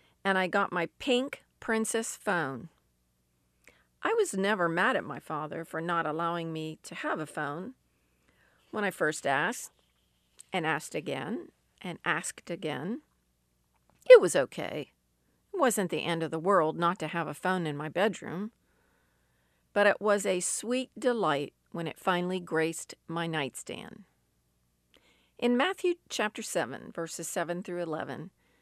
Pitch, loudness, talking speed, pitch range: 170 Hz, -30 LUFS, 145 wpm, 145-205 Hz